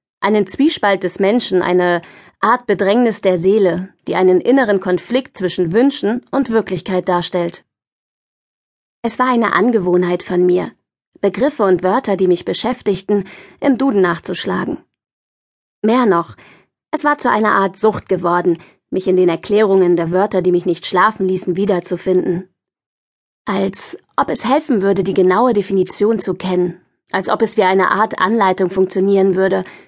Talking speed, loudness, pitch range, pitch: 145 wpm, -16 LUFS, 180-215 Hz, 190 Hz